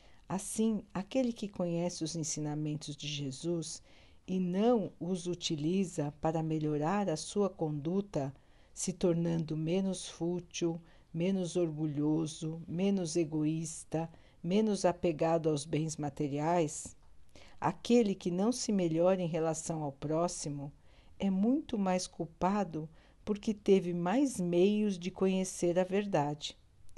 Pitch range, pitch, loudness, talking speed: 155-190 Hz, 170 Hz, -34 LUFS, 115 wpm